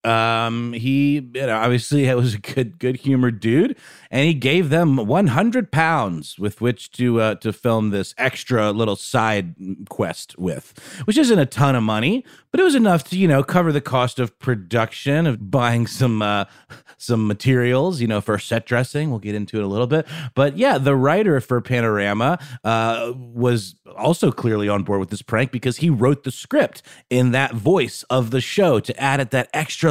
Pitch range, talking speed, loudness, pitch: 115-140 Hz, 195 wpm, -19 LUFS, 125 Hz